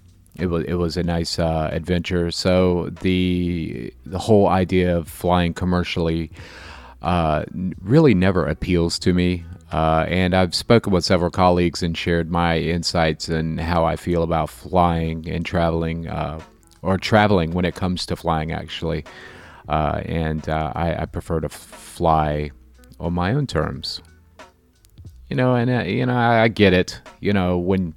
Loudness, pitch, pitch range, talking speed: -20 LUFS, 85 Hz, 80-90 Hz, 165 wpm